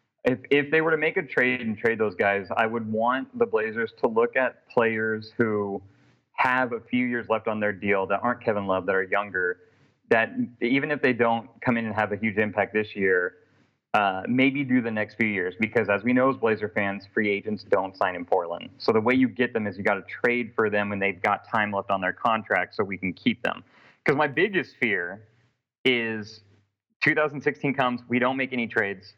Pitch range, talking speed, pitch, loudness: 105-125 Hz, 225 wpm, 115 Hz, -25 LUFS